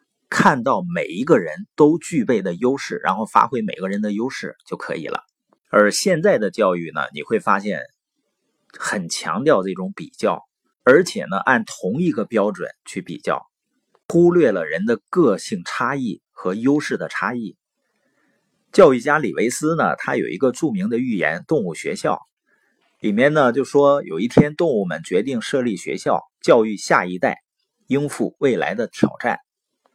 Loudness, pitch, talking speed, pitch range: -19 LUFS, 140 Hz, 240 characters per minute, 105-160 Hz